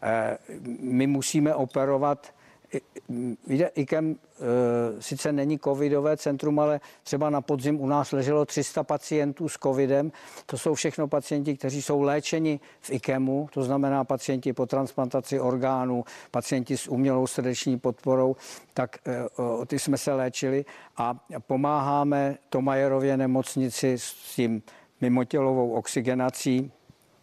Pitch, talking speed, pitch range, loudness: 135 Hz, 130 wpm, 130-145 Hz, -27 LUFS